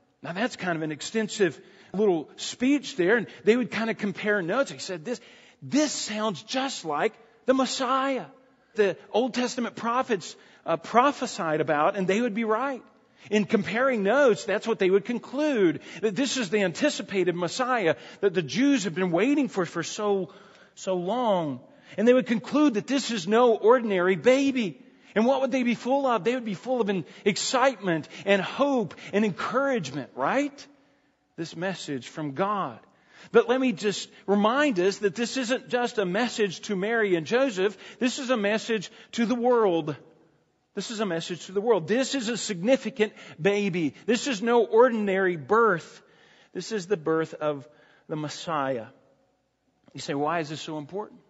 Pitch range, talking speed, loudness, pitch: 185-250 Hz, 175 wpm, -26 LUFS, 215 Hz